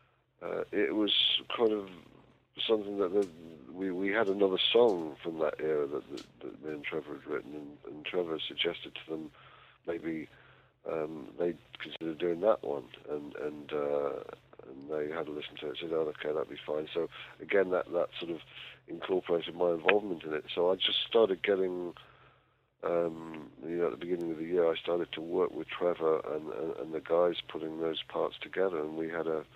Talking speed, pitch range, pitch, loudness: 195 wpm, 80-95 Hz, 85 Hz, -33 LUFS